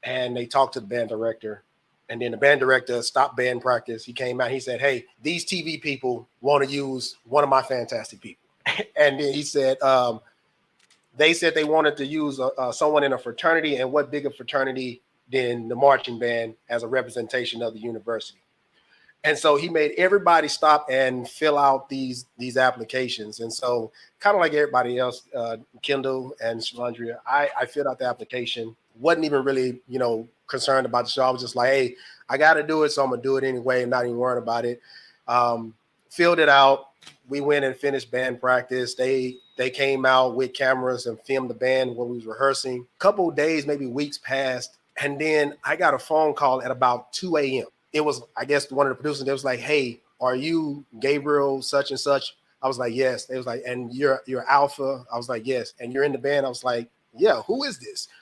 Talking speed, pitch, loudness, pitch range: 215 wpm, 130 Hz, -23 LUFS, 125-145 Hz